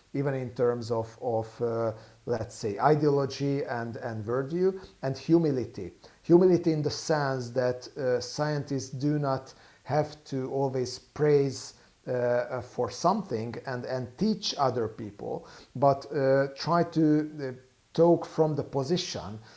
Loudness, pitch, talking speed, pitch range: -28 LUFS, 135 Hz, 135 wpm, 125-150 Hz